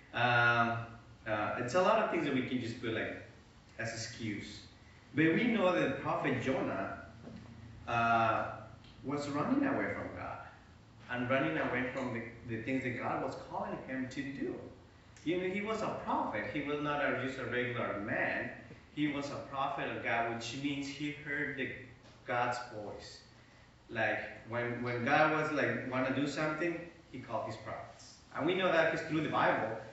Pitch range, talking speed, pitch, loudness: 115-140 Hz, 180 wpm, 125 Hz, -35 LUFS